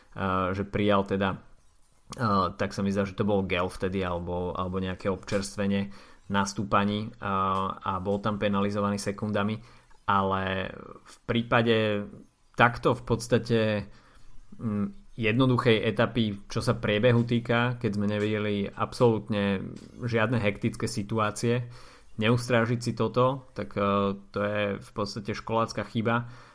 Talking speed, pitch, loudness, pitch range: 115 wpm, 105 Hz, -28 LUFS, 100-115 Hz